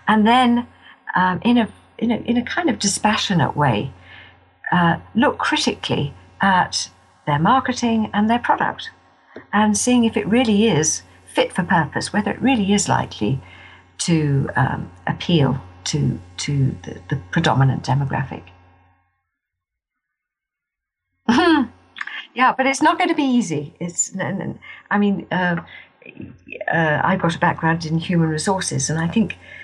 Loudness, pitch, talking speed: -19 LUFS, 175 Hz, 140 wpm